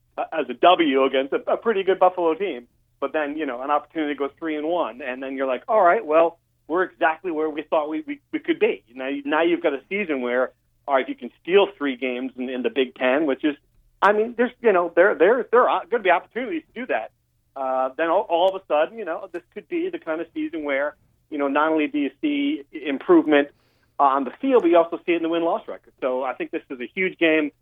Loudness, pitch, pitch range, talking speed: -22 LUFS, 155 Hz, 135-190 Hz, 260 wpm